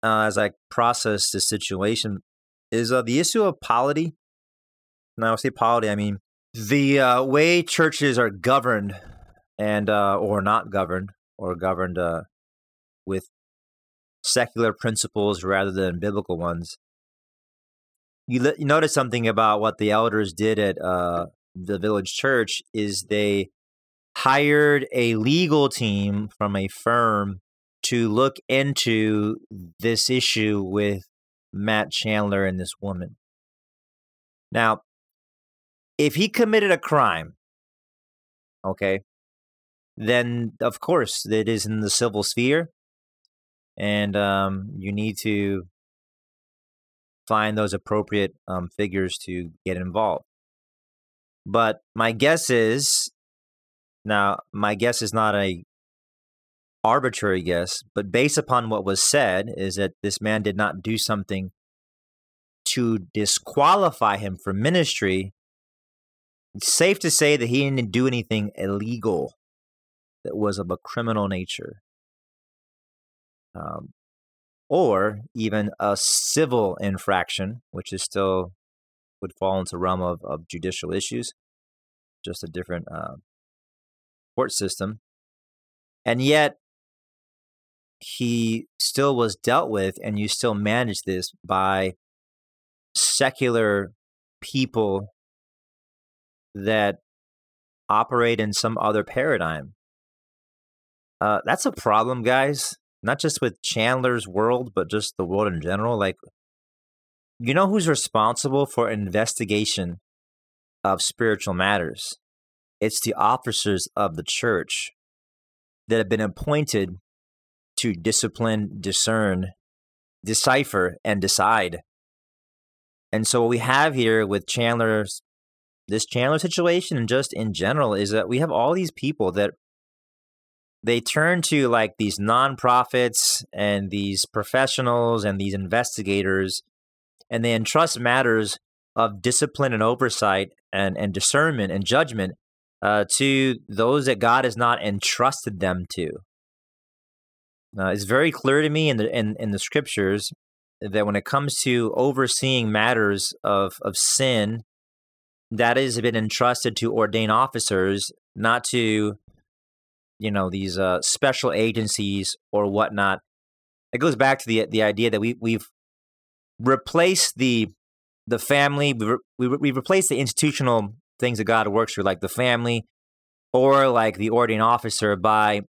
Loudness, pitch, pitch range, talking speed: -22 LUFS, 105 Hz, 95-120 Hz, 125 wpm